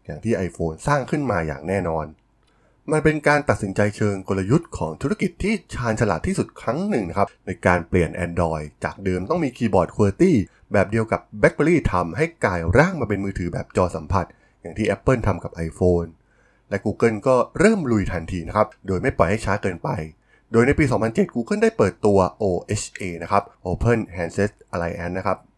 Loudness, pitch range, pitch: -22 LUFS, 90-125 Hz, 100 Hz